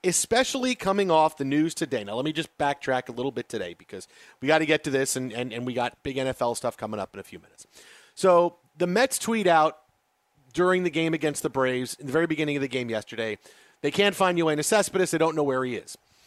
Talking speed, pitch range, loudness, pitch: 245 wpm, 130-175 Hz, -25 LUFS, 150 Hz